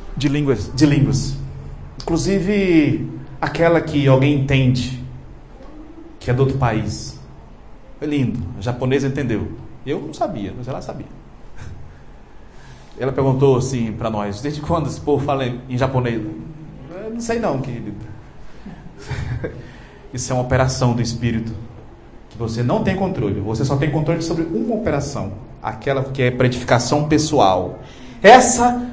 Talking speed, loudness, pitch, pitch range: 135 wpm, -19 LUFS, 135 Hz, 120-155 Hz